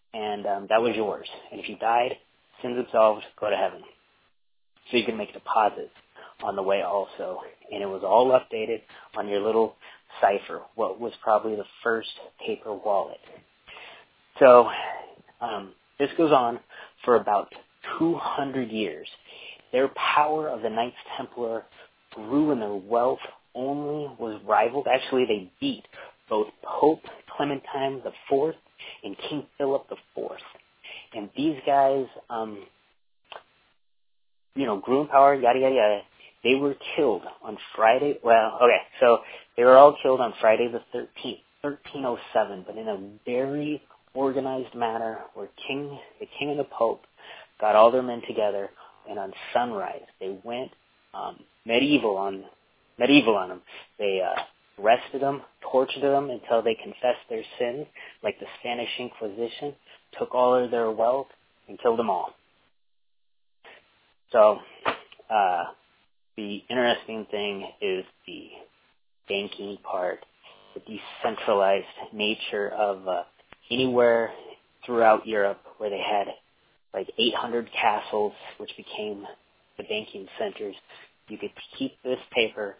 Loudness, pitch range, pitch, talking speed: -25 LUFS, 110-140 Hz, 120 Hz, 140 wpm